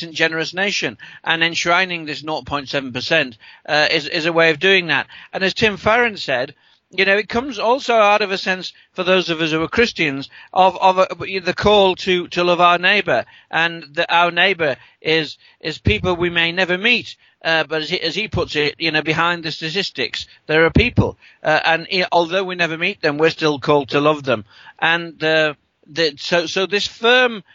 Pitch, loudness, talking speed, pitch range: 170 Hz, -17 LUFS, 205 wpm, 160-190 Hz